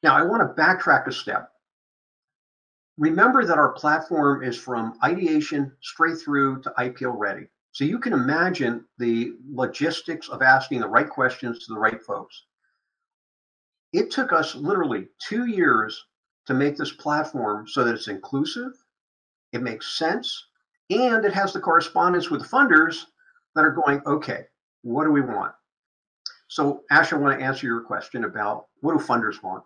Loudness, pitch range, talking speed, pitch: -22 LUFS, 125-170 Hz, 160 wpm, 145 Hz